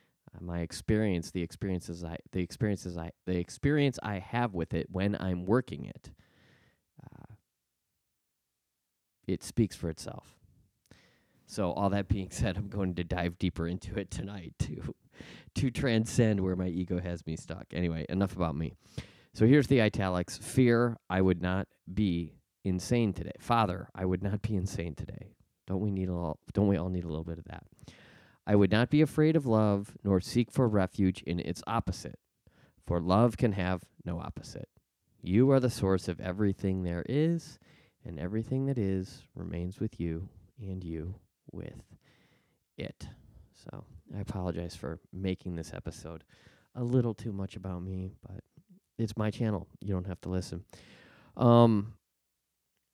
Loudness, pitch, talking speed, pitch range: -31 LUFS, 95 Hz, 160 wpm, 90-110 Hz